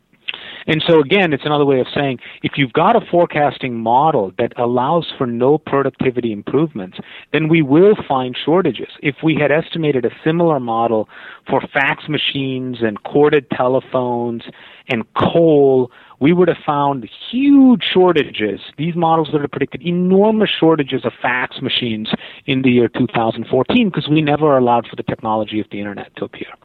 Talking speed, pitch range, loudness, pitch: 160 wpm, 125-160 Hz, -16 LUFS, 140 Hz